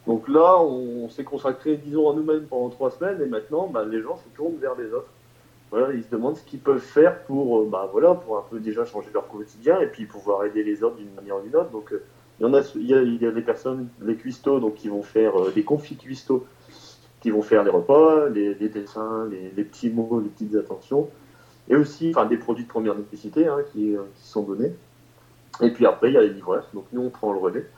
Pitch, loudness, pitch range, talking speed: 120 Hz, -23 LUFS, 105-145 Hz, 250 wpm